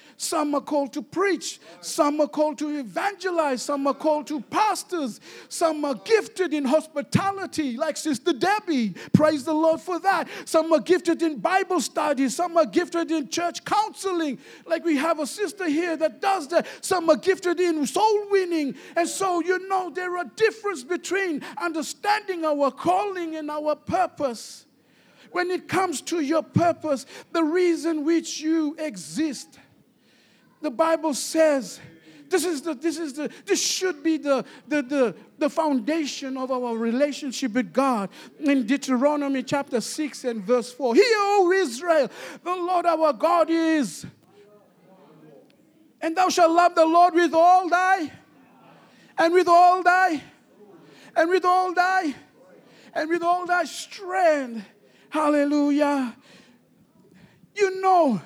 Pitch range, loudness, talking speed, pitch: 285-355 Hz, -23 LUFS, 145 wpm, 320 Hz